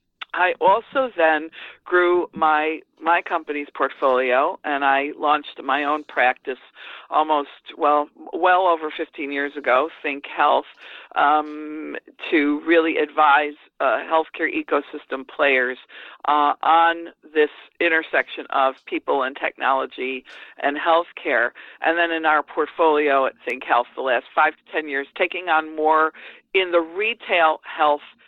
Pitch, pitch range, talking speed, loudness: 155 Hz, 145-165 Hz, 130 wpm, -21 LUFS